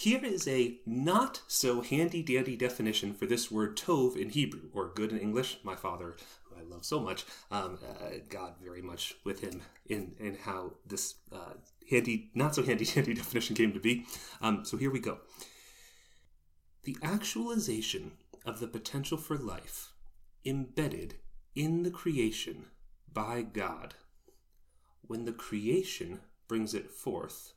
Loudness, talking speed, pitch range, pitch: -34 LUFS, 150 wpm, 100-135 Hz, 115 Hz